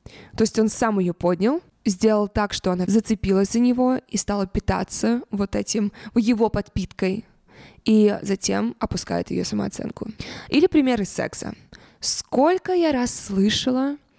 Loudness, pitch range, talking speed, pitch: -22 LUFS, 200-245 Hz, 135 wpm, 220 Hz